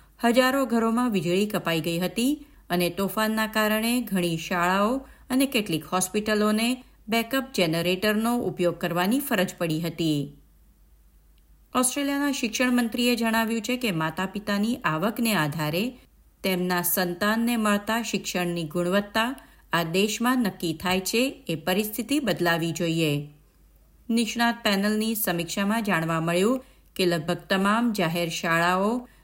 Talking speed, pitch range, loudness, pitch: 115 wpm, 175-230 Hz, -25 LUFS, 200 Hz